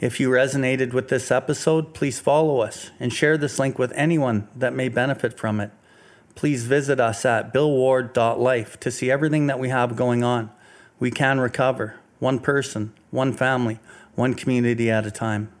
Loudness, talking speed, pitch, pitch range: -22 LUFS, 175 wpm, 130 Hz, 120-135 Hz